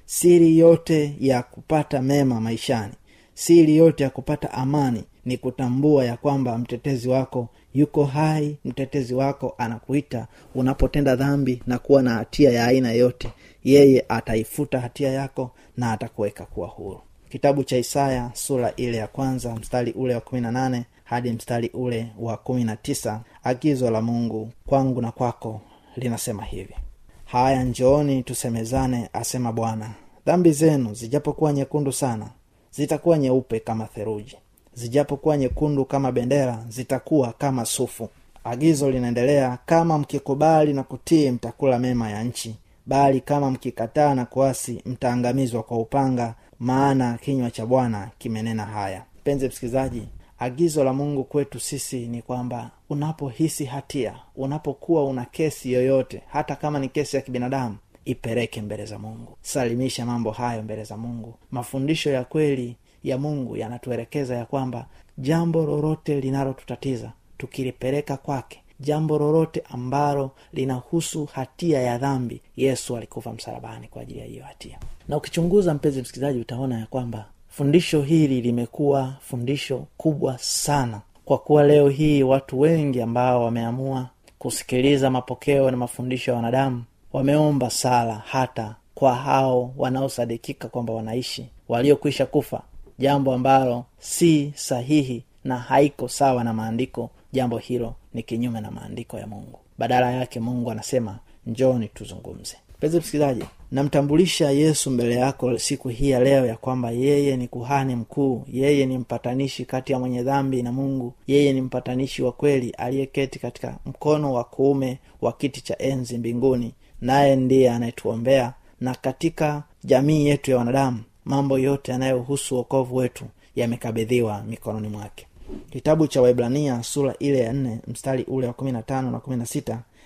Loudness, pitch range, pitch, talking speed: -23 LUFS, 120-140 Hz, 130 Hz, 135 wpm